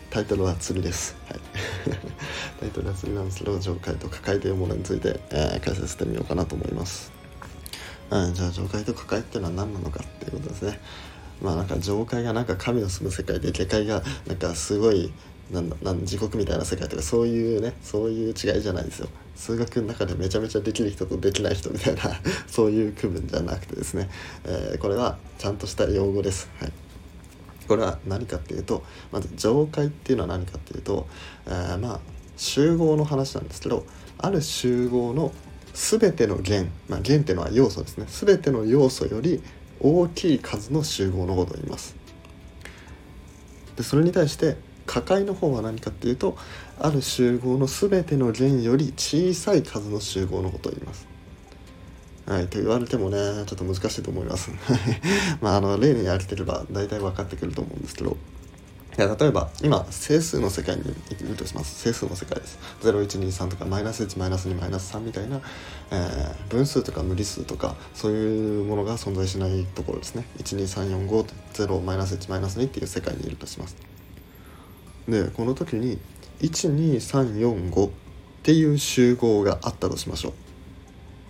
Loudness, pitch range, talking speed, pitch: -25 LUFS, 90-115 Hz, 315 characters per minute, 95 Hz